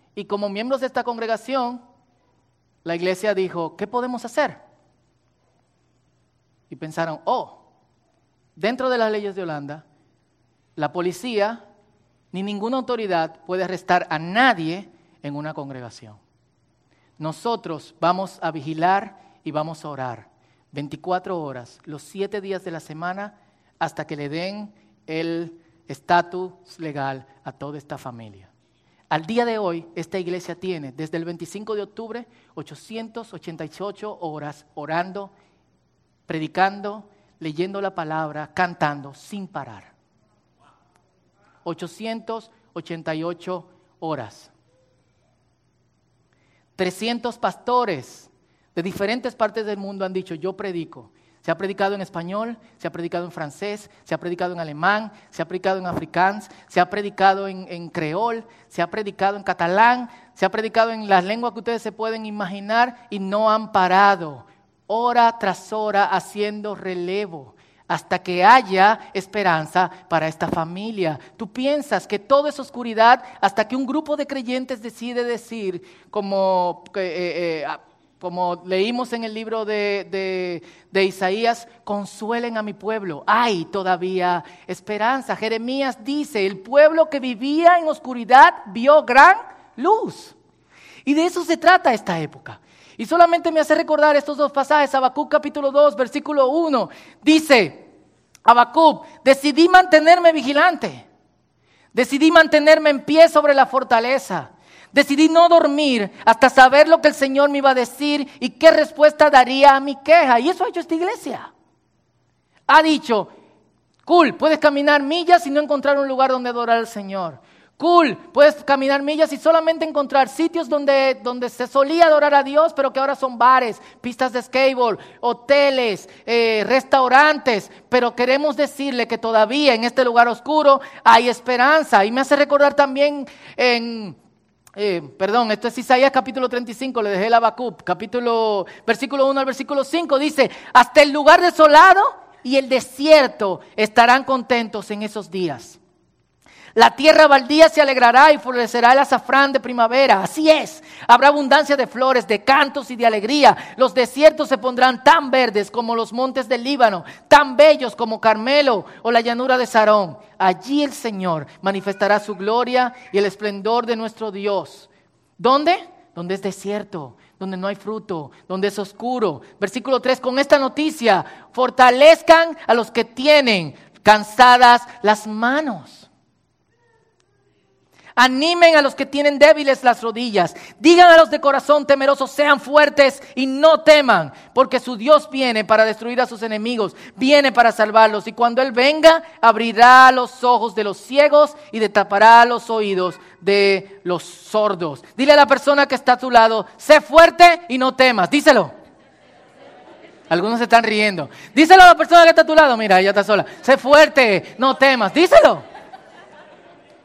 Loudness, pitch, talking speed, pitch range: -16 LUFS, 230 Hz, 145 wpm, 190-275 Hz